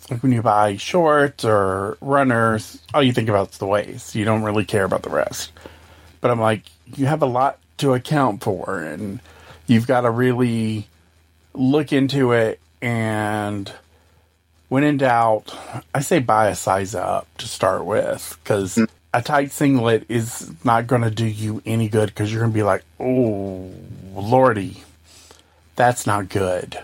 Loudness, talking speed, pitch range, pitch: -20 LUFS, 165 wpm, 100-130 Hz, 110 Hz